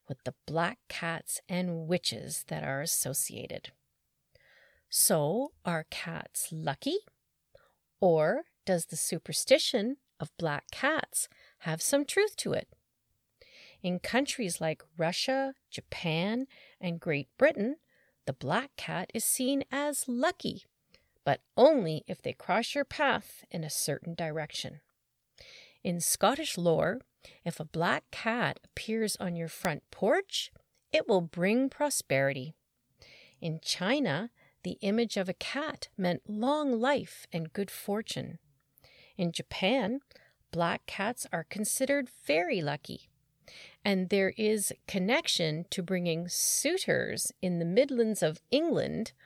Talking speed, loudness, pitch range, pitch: 120 wpm, -31 LUFS, 170-260 Hz, 195 Hz